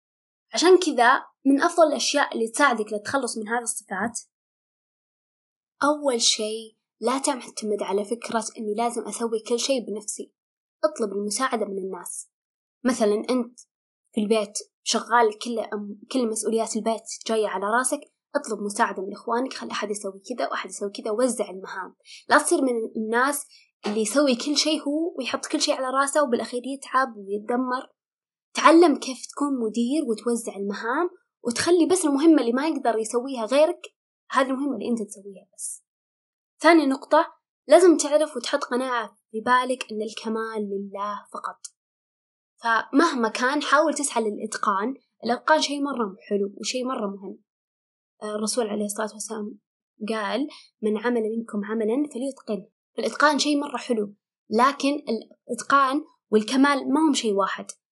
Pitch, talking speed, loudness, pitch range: 240 Hz, 140 wpm, -24 LUFS, 215-280 Hz